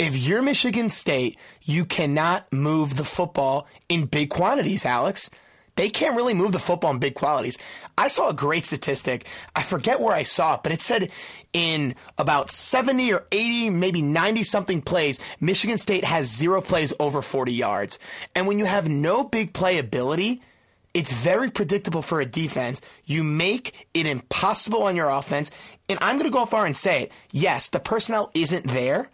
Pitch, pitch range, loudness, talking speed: 170 Hz, 145-200 Hz, -23 LUFS, 180 wpm